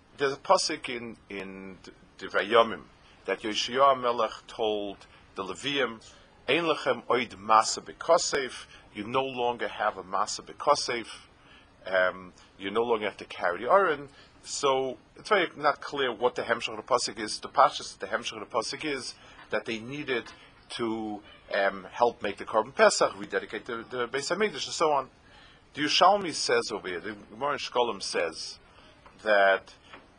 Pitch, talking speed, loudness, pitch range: 110 Hz, 155 wpm, -28 LUFS, 95-130 Hz